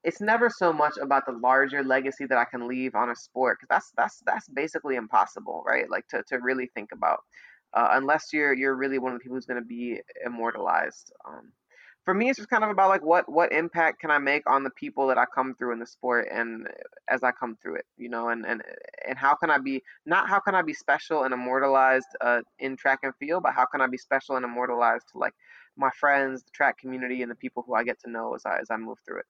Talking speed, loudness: 255 wpm, -26 LUFS